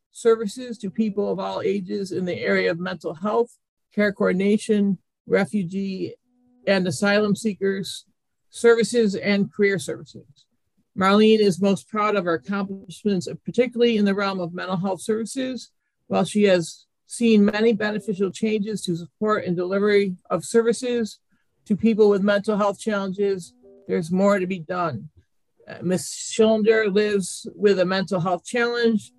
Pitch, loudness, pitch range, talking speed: 205 Hz, -22 LUFS, 190-220 Hz, 140 wpm